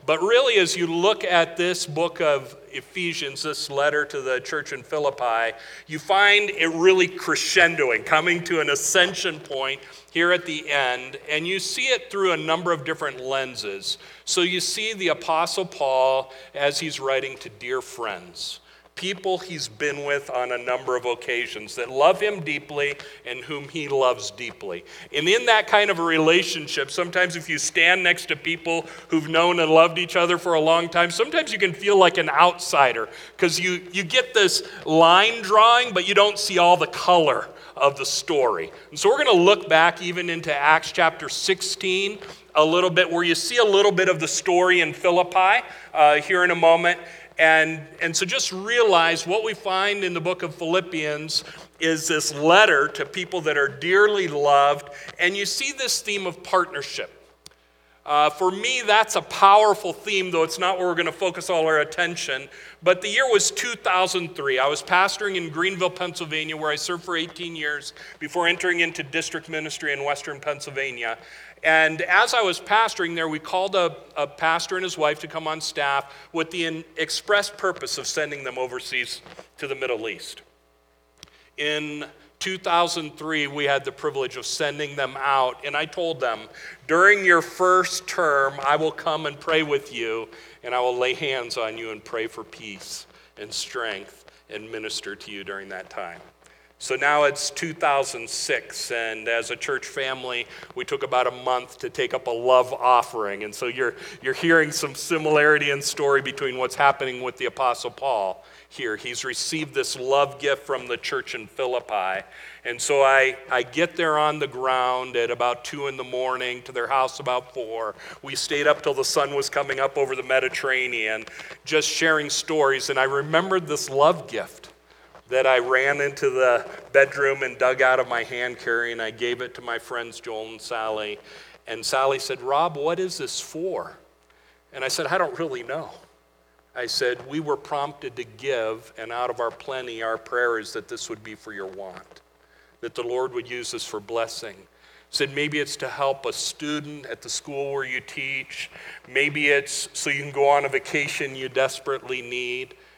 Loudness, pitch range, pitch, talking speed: -22 LUFS, 130-180 Hz, 155 Hz, 190 wpm